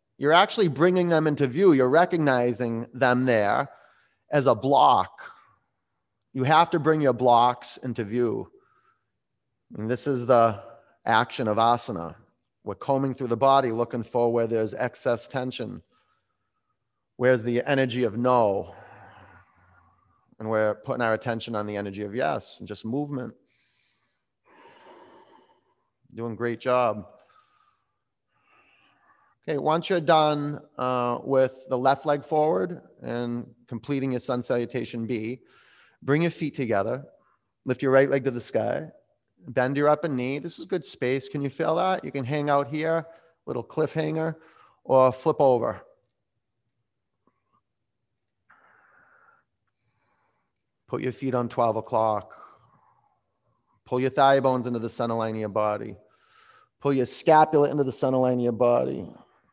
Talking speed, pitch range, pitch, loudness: 140 wpm, 115-145 Hz, 125 Hz, -24 LUFS